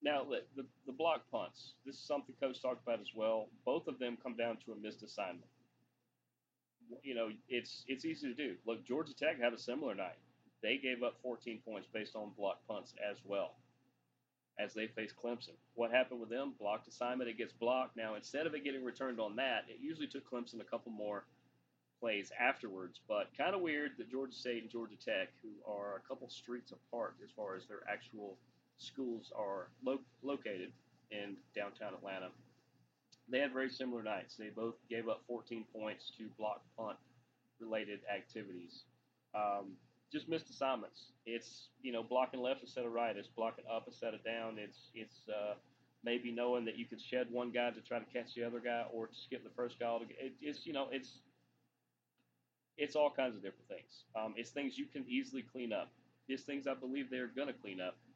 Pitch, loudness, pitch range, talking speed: 120 Hz, -42 LUFS, 110-130 Hz, 200 wpm